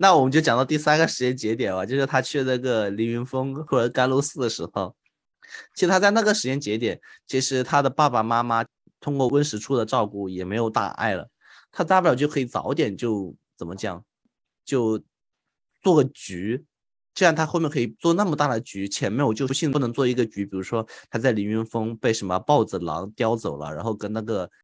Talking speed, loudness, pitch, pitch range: 310 characters per minute, -23 LUFS, 125 Hz, 110-145 Hz